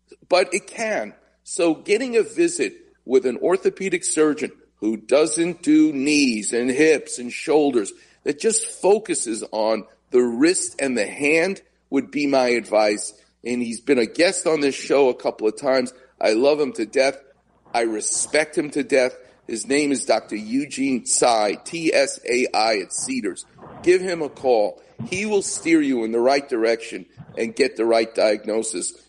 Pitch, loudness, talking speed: 155 Hz, -21 LUFS, 170 wpm